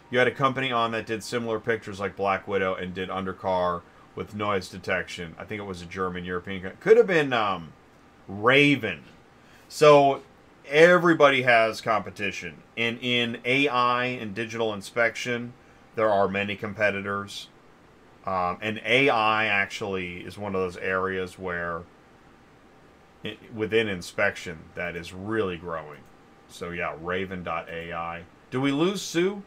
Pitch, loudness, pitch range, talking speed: 100 Hz, -25 LUFS, 90-115 Hz, 140 wpm